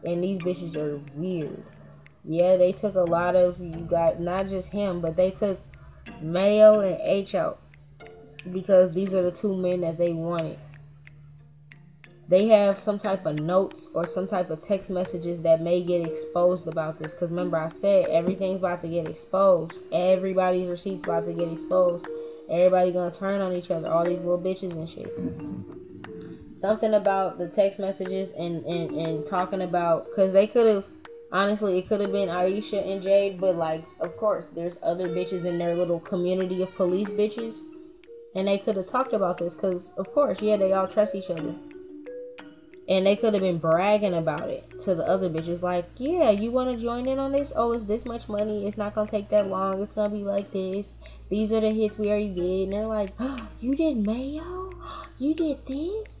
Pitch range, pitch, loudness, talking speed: 170-210 Hz, 185 Hz, -25 LUFS, 195 wpm